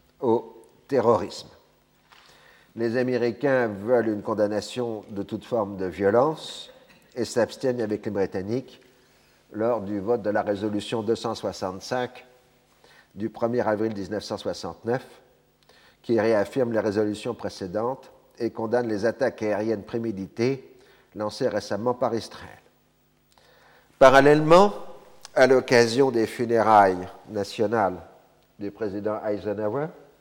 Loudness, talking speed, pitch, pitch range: -24 LUFS, 105 wpm, 110 Hz, 105-125 Hz